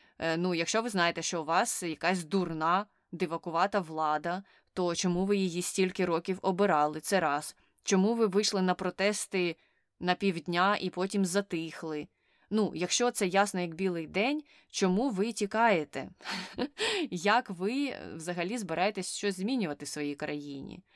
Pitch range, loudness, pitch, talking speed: 170-205 Hz, -31 LUFS, 185 Hz, 140 wpm